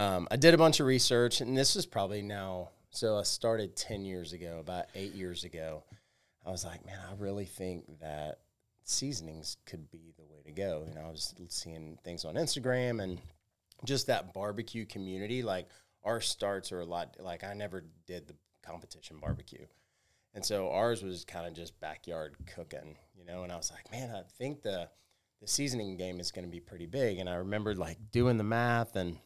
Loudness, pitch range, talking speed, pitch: -34 LUFS, 85-115 Hz, 200 wpm, 95 Hz